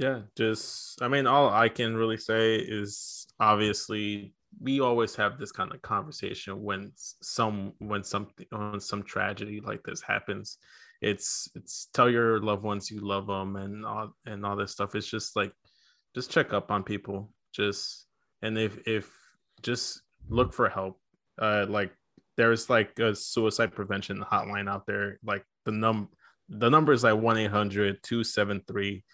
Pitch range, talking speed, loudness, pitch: 100-110 Hz, 160 wpm, -29 LUFS, 105 Hz